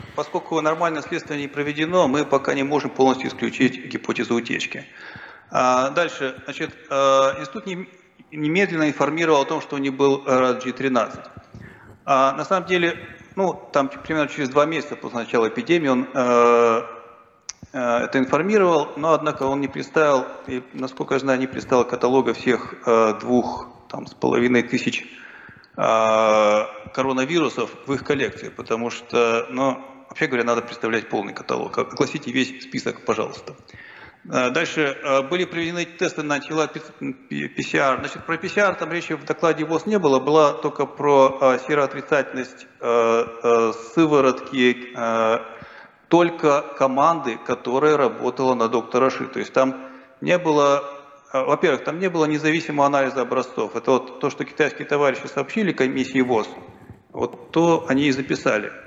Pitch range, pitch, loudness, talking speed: 125-155 Hz, 140 Hz, -21 LUFS, 135 wpm